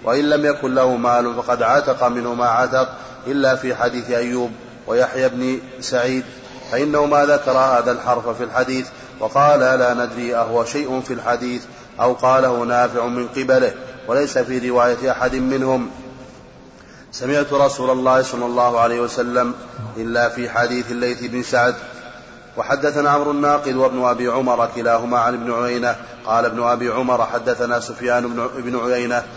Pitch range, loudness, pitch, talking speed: 120-130 Hz, -18 LUFS, 125 Hz, 145 wpm